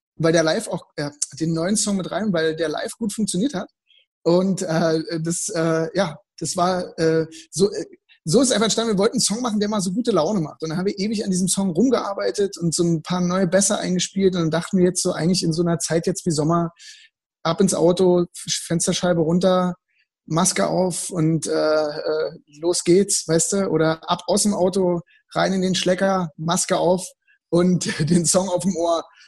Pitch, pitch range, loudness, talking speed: 180 Hz, 165-195 Hz, -21 LUFS, 210 wpm